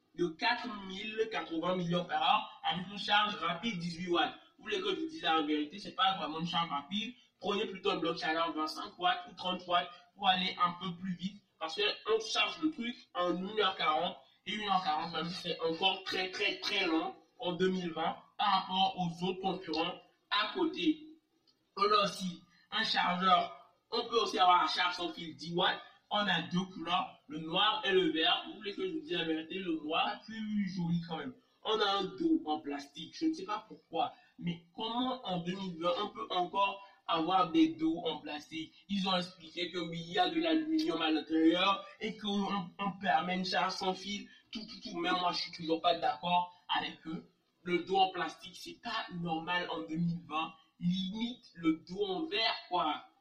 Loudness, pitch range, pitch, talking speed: -34 LUFS, 170-225 Hz, 185 Hz, 195 wpm